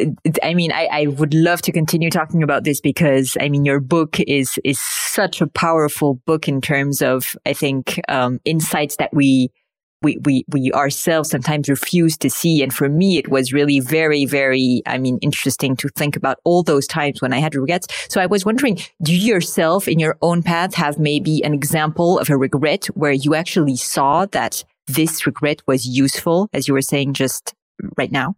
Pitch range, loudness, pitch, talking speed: 140-165 Hz, -17 LUFS, 150 Hz, 200 wpm